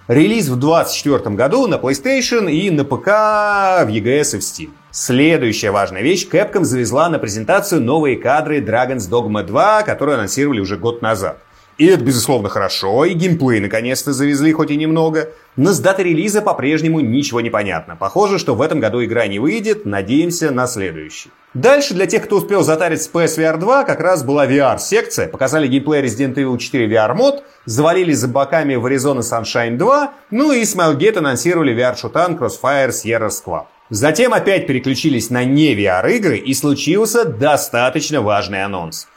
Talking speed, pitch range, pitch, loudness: 165 wpm, 125-175 Hz, 145 Hz, -15 LUFS